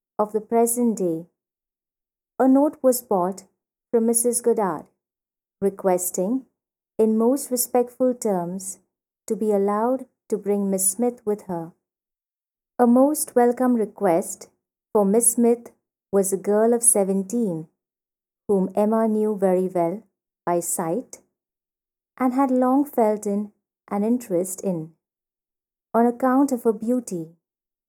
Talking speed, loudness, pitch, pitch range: 125 wpm, -22 LUFS, 215 Hz, 190-245 Hz